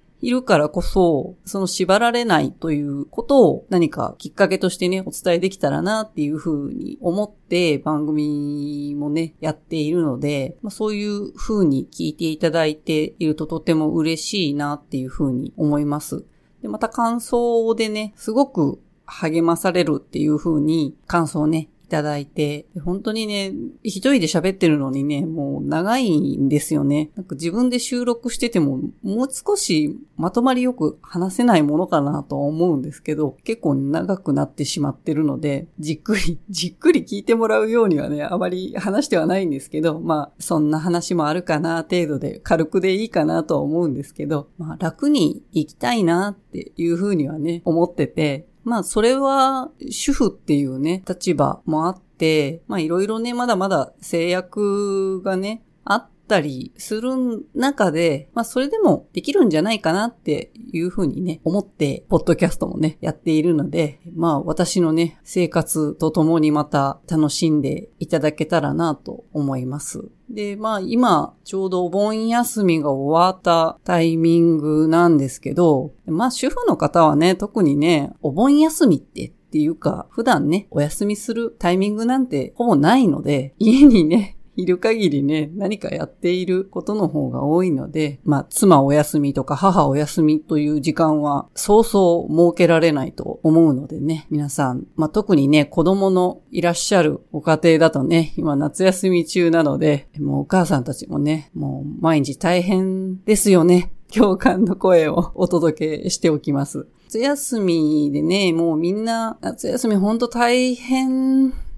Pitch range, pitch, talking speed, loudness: 155-205 Hz, 170 Hz, 325 characters per minute, -19 LUFS